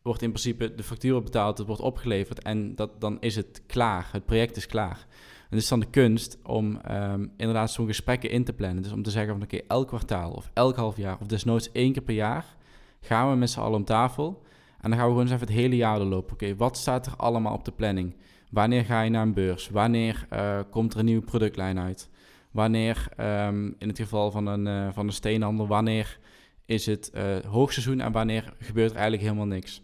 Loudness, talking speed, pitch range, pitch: -27 LUFS, 235 wpm, 105-120 Hz, 110 Hz